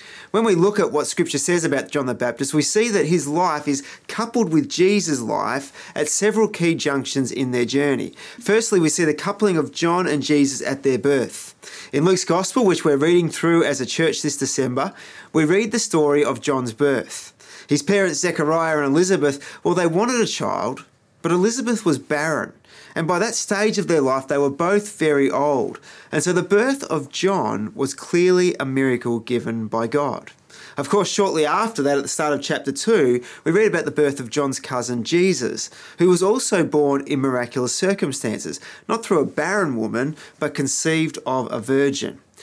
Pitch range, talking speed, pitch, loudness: 140-185 Hz, 190 wpm, 150 Hz, -20 LUFS